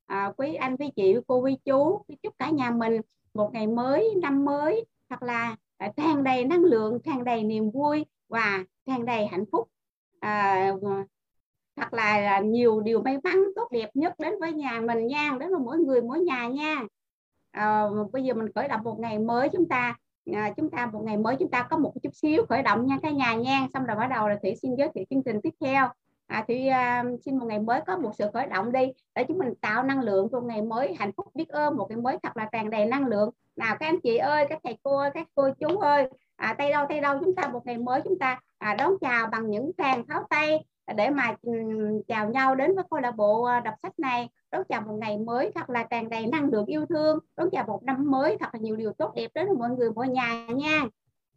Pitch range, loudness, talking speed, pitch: 220-295 Hz, -27 LUFS, 245 wpm, 250 Hz